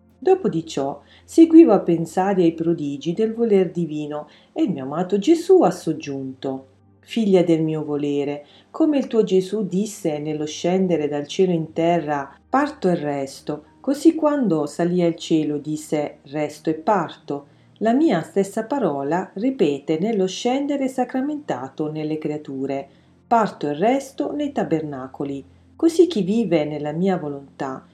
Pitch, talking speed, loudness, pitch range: 170 Hz, 140 wpm, -21 LUFS, 150-220 Hz